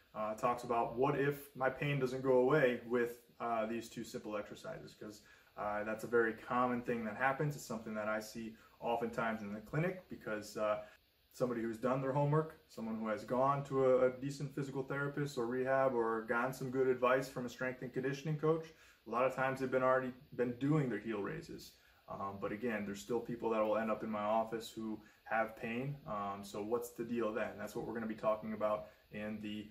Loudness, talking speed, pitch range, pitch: -38 LUFS, 220 wpm, 110-130 Hz, 120 Hz